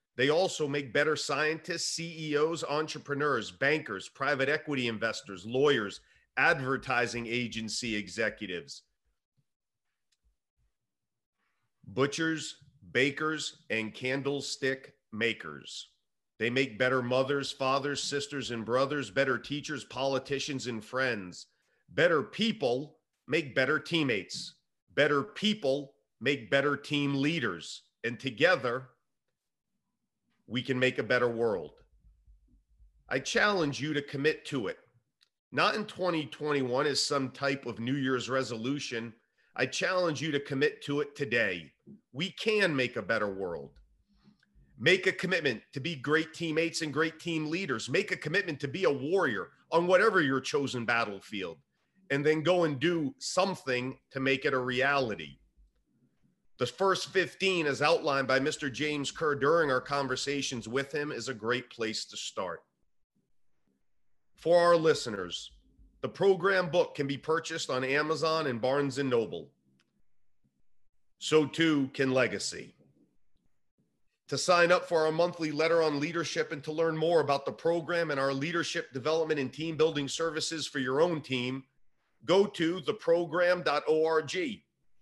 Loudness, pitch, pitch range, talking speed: -30 LUFS, 140 Hz, 130-160 Hz, 130 wpm